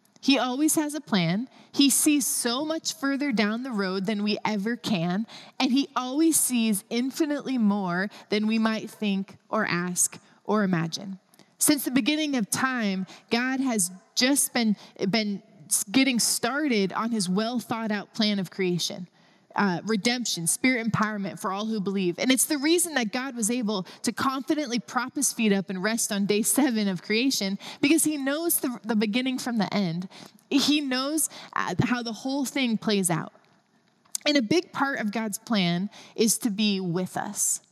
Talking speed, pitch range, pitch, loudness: 175 wpm, 200-260 Hz, 220 Hz, -25 LUFS